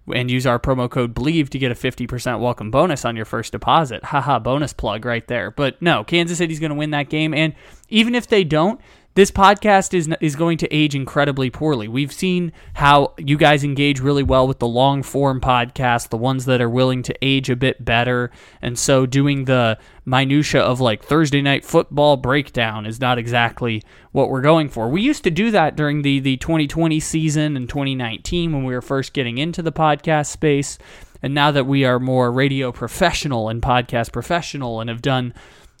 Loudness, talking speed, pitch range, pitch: -18 LUFS, 200 wpm, 125-155 Hz, 140 Hz